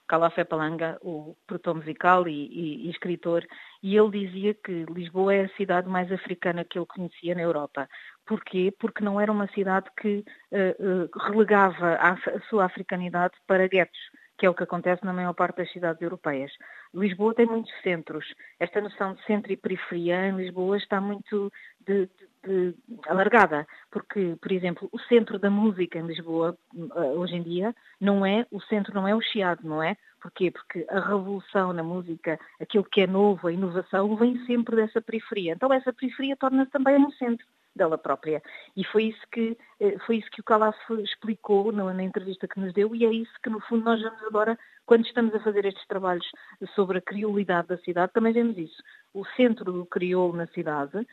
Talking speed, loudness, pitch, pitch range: 185 wpm, -26 LUFS, 195 Hz, 175-215 Hz